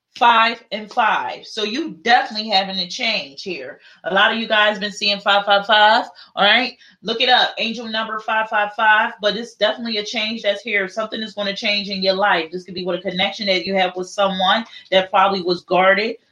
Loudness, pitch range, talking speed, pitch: -18 LUFS, 195-225 Hz, 220 wpm, 210 Hz